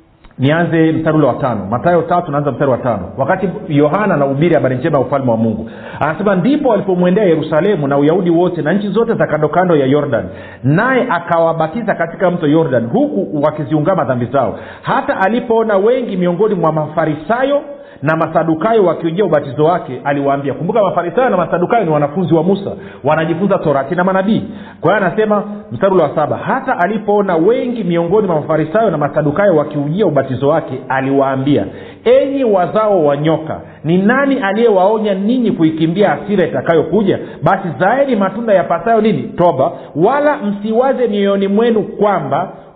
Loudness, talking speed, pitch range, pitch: -14 LUFS, 150 wpm, 150-210 Hz, 175 Hz